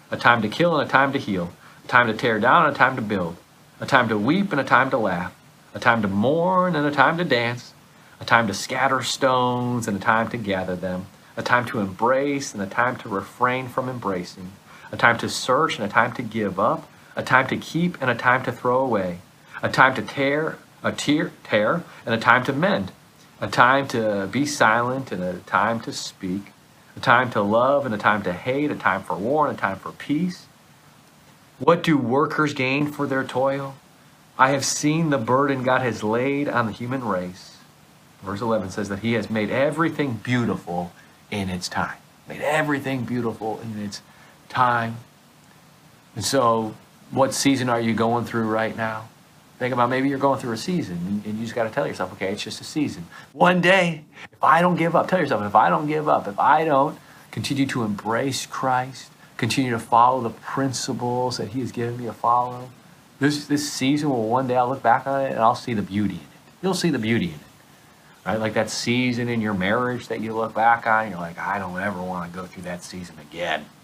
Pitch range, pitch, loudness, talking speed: 110-135 Hz, 120 Hz, -22 LUFS, 215 wpm